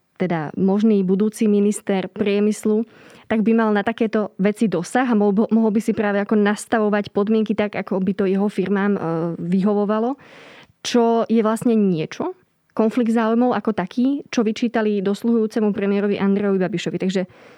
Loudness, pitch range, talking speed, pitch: -20 LUFS, 200-225 Hz, 145 wpm, 210 Hz